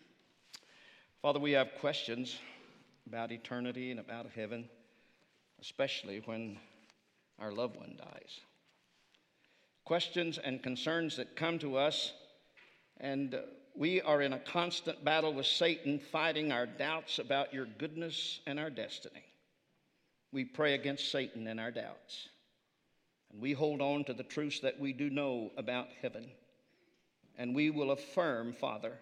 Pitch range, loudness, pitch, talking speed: 125-155 Hz, -37 LUFS, 140 Hz, 135 wpm